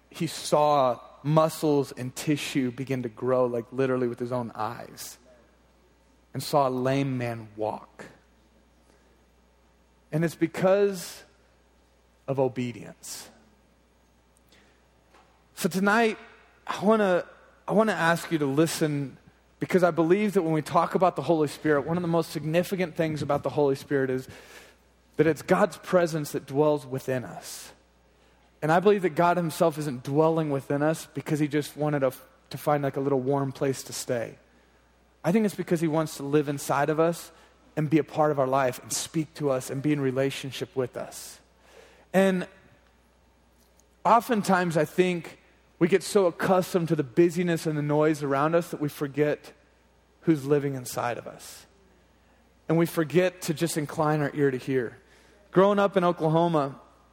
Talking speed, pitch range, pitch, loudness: 165 wpm, 125-165 Hz, 145 Hz, -26 LUFS